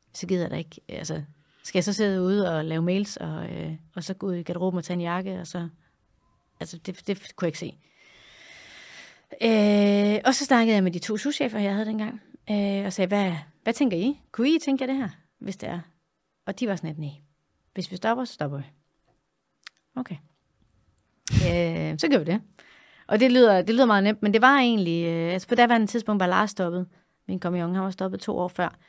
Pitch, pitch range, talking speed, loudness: 190 Hz, 170-215 Hz, 225 wpm, -25 LUFS